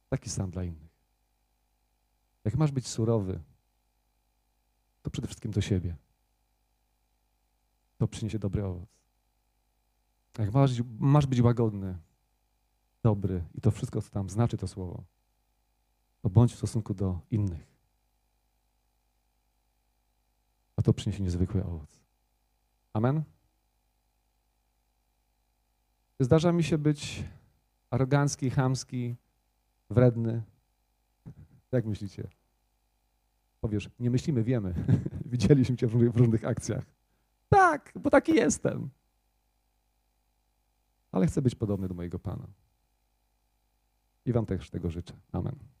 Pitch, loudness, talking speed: 75 Hz, -29 LUFS, 105 wpm